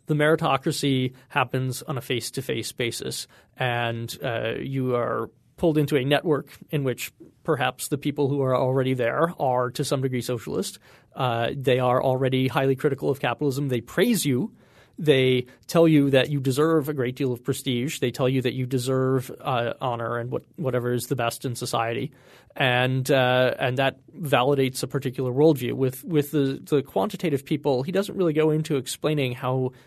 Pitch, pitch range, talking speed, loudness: 135 Hz, 125-145 Hz, 175 wpm, -24 LUFS